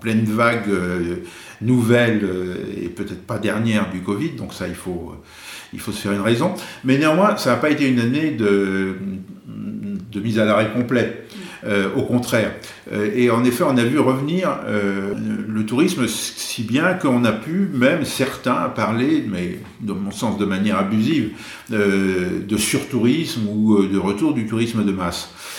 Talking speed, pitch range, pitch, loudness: 175 wpm, 100-125 Hz, 110 Hz, -20 LUFS